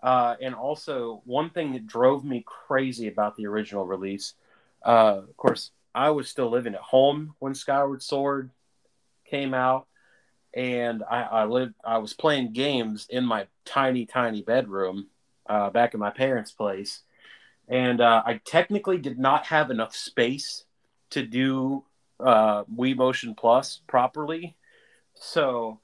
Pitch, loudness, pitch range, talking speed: 130 Hz, -25 LUFS, 115-140 Hz, 145 wpm